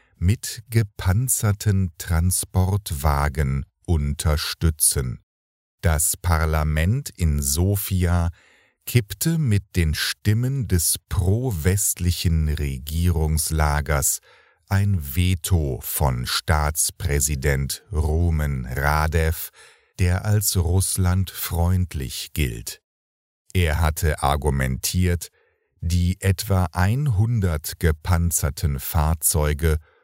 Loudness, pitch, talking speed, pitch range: -22 LUFS, 85 Hz, 70 wpm, 75-95 Hz